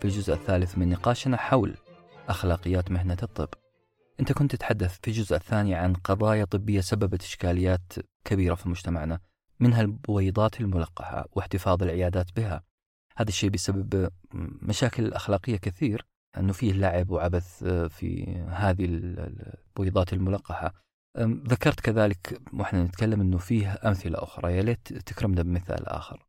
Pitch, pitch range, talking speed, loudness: 95 Hz, 90-110 Hz, 130 wpm, -28 LUFS